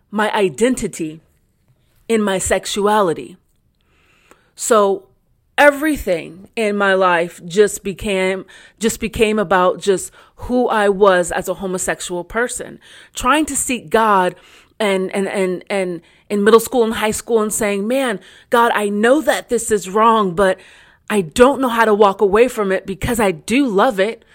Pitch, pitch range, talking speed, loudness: 205 Hz, 190-230 Hz, 155 wpm, -16 LUFS